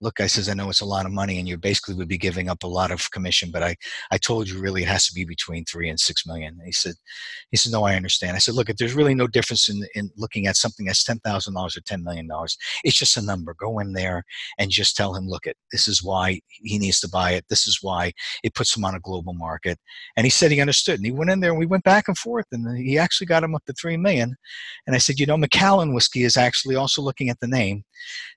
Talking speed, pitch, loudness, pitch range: 285 wpm, 105 Hz, -21 LUFS, 95-130 Hz